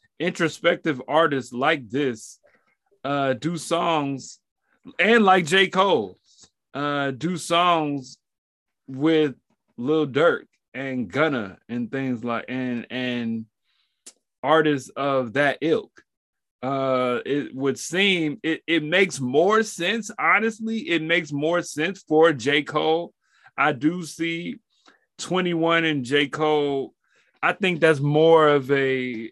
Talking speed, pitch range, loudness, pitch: 120 wpm, 135-170 Hz, -22 LUFS, 155 Hz